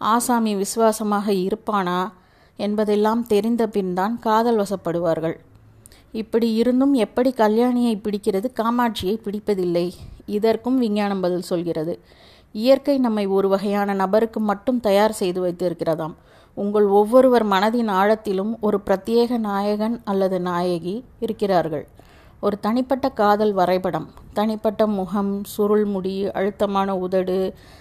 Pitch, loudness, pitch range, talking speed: 205 Hz, -21 LUFS, 190-225 Hz, 105 wpm